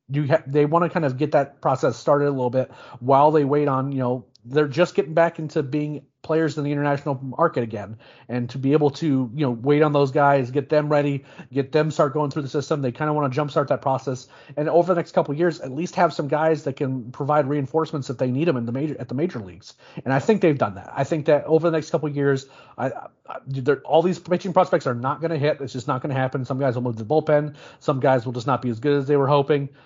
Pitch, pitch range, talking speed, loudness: 145 Hz, 135-155 Hz, 280 wpm, -22 LUFS